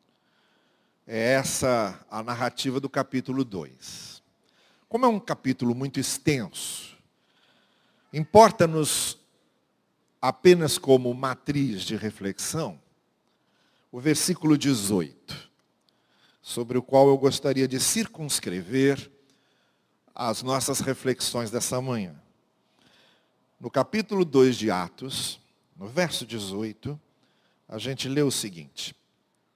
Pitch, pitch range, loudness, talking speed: 130 Hz, 120-145 Hz, -25 LUFS, 95 wpm